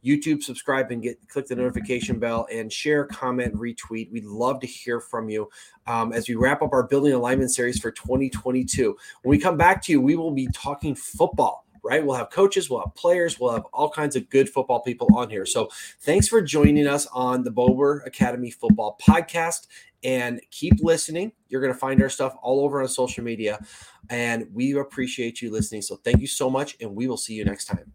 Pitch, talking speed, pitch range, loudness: 130 Hz, 215 wpm, 120-145 Hz, -23 LUFS